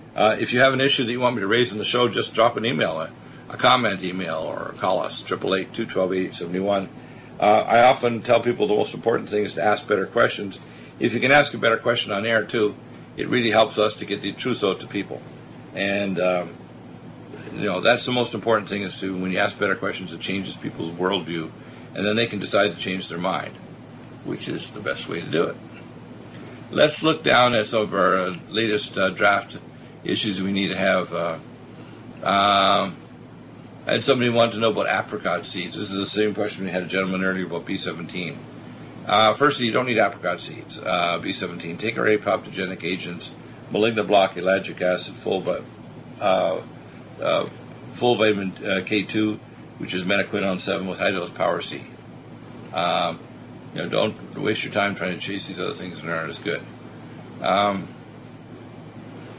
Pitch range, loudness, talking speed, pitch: 95-120 Hz, -22 LUFS, 190 wpm, 105 Hz